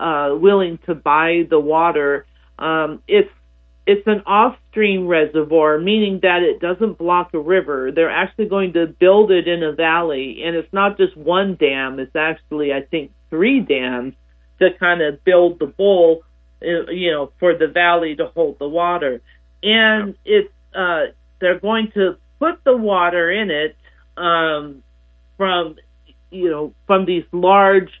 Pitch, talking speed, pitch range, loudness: 170 Hz, 155 wpm, 150-190 Hz, -17 LUFS